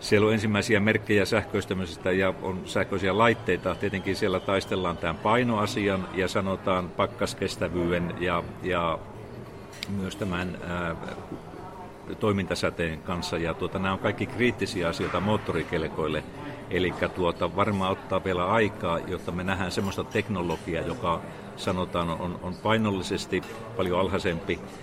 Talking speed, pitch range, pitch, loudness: 120 wpm, 90-105 Hz, 95 Hz, -27 LUFS